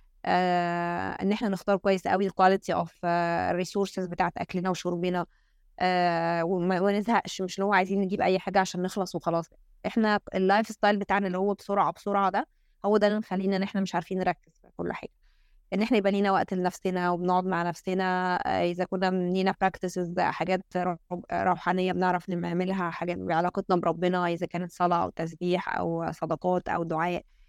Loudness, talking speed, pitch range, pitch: -28 LUFS, 160 wpm, 175-195 Hz, 185 Hz